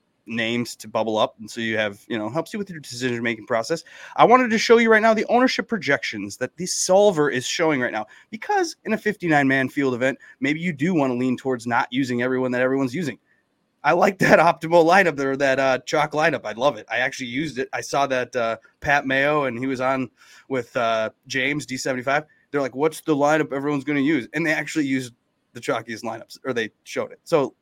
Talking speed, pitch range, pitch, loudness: 230 wpm, 125-165 Hz, 140 Hz, -22 LUFS